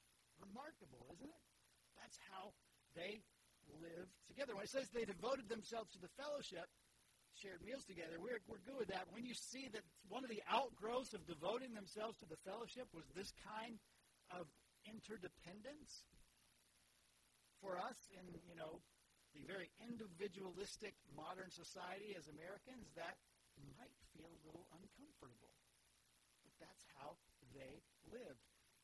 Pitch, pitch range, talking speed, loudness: 195 Hz, 160-225 Hz, 140 wpm, -52 LUFS